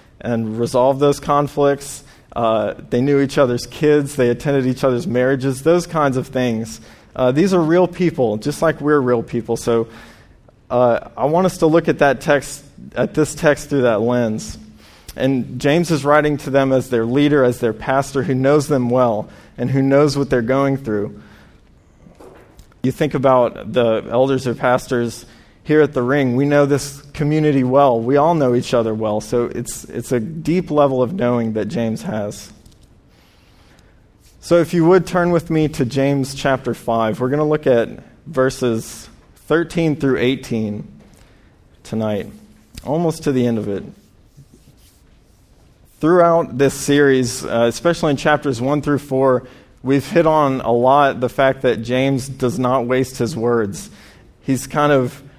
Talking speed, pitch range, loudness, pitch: 170 wpm, 115-145 Hz, -17 LUFS, 130 Hz